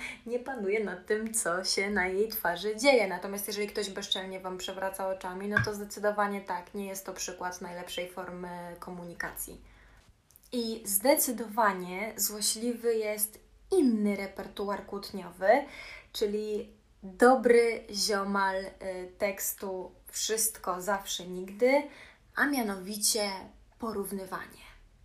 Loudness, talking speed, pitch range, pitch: -30 LUFS, 110 wpm, 185-220 Hz, 200 Hz